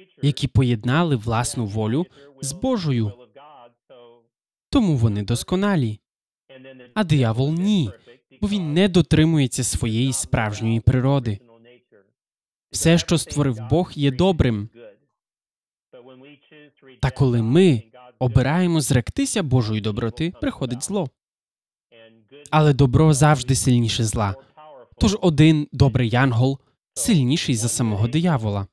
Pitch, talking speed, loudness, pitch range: 135 Hz, 100 wpm, -20 LUFS, 120-155 Hz